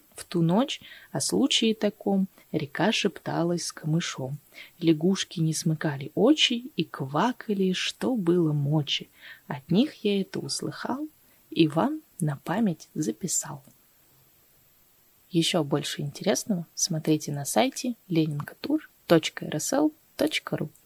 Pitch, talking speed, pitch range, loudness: 175 Hz, 105 wpm, 160-225 Hz, -27 LUFS